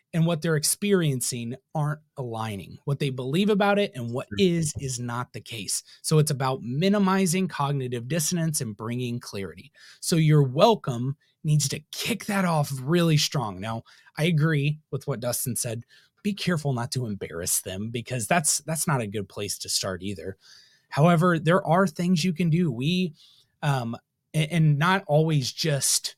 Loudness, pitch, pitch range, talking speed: -25 LUFS, 145 Hz, 125-170 Hz, 170 wpm